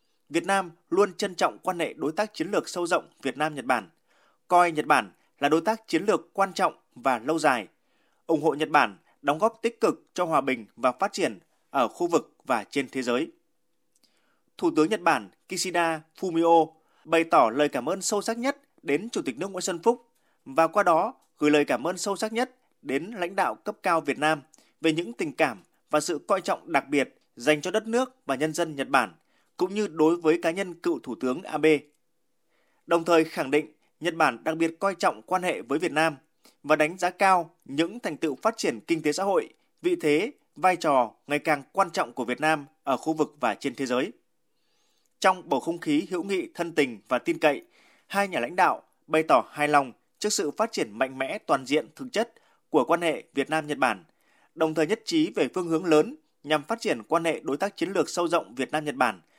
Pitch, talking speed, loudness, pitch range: 165 Hz, 225 wpm, -26 LUFS, 150-195 Hz